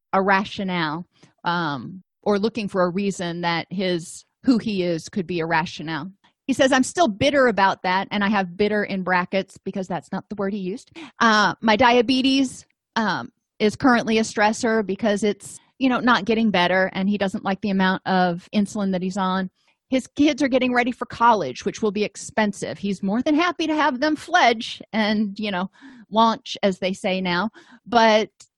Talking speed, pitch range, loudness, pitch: 195 wpm, 185-235 Hz, -21 LUFS, 205 Hz